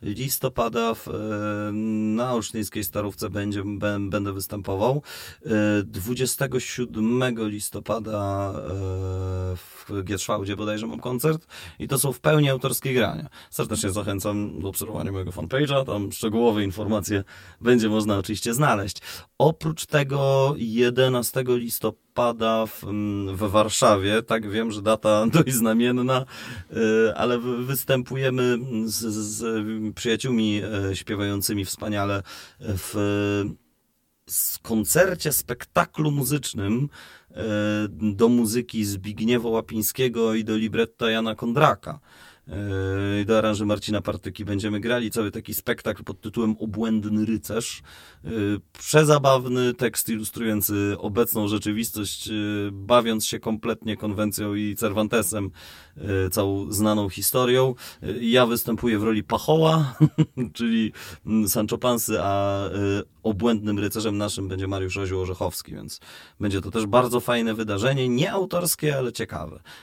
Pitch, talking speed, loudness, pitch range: 105 Hz, 105 wpm, -24 LUFS, 100-120 Hz